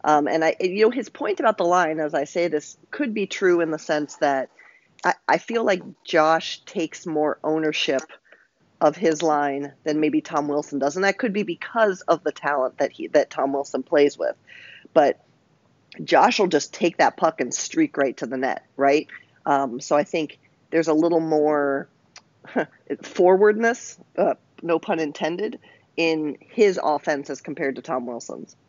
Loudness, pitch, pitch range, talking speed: -22 LUFS, 160 Hz, 145-185 Hz, 185 wpm